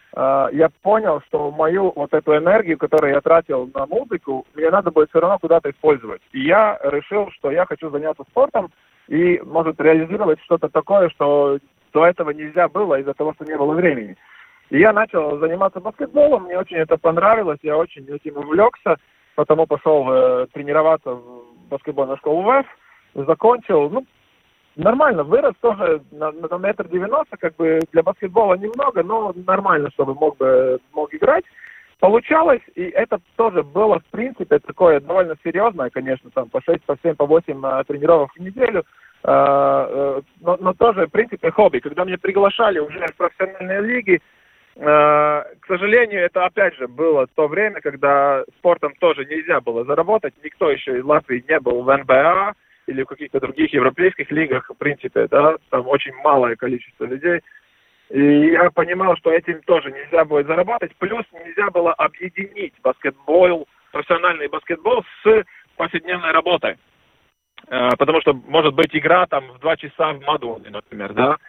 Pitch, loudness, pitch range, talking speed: 165 Hz, -18 LUFS, 150-205 Hz, 160 wpm